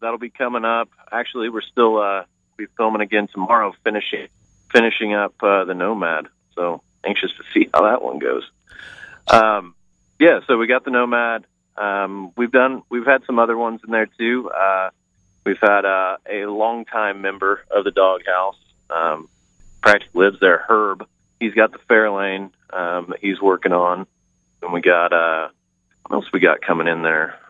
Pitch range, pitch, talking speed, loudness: 95-115 Hz, 100 Hz, 170 wpm, -18 LUFS